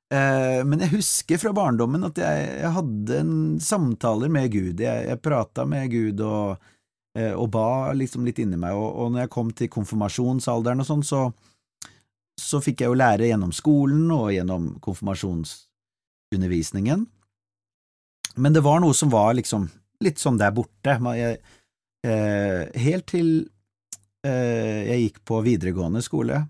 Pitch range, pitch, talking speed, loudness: 100-135 Hz, 115 Hz, 140 wpm, -23 LUFS